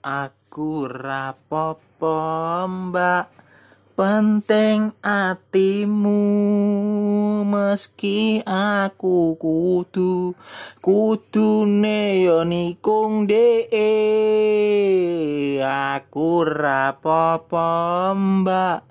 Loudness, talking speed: -20 LUFS, 45 wpm